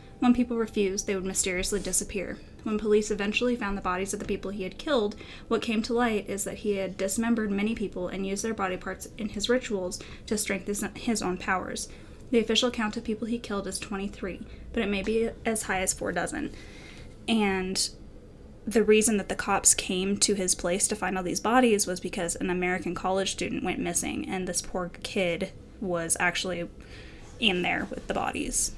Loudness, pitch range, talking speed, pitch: -28 LUFS, 185-220 Hz, 200 wpm, 200 Hz